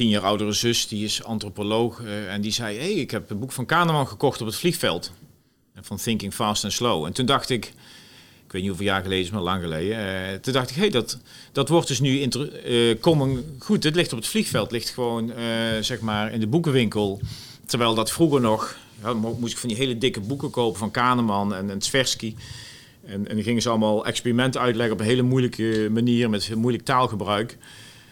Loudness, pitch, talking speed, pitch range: -23 LUFS, 115 Hz, 225 wpm, 105-130 Hz